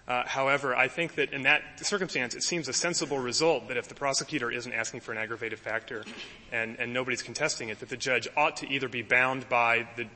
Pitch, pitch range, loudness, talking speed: 130 Hz, 120-150 Hz, -28 LUFS, 235 wpm